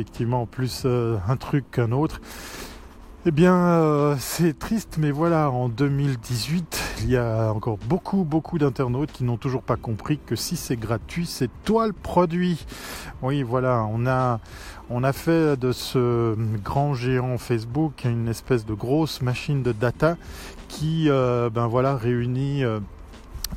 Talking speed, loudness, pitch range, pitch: 160 wpm, -24 LUFS, 115-150 Hz, 130 Hz